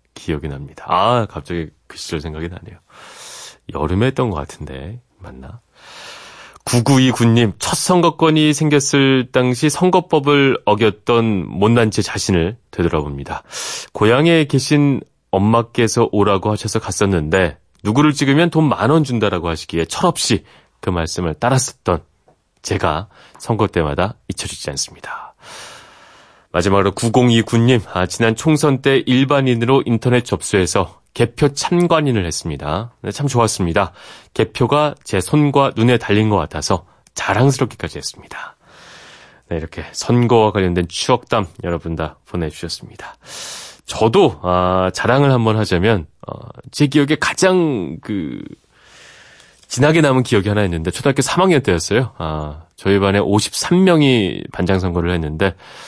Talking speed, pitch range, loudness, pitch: 295 characters per minute, 90-135 Hz, -16 LUFS, 110 Hz